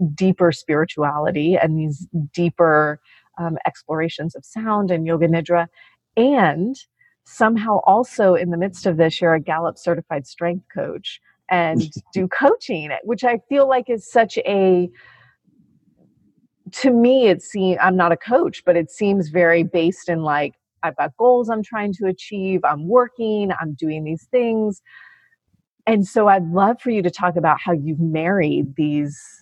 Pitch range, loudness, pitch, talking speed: 165-220 Hz, -19 LUFS, 180 Hz, 155 wpm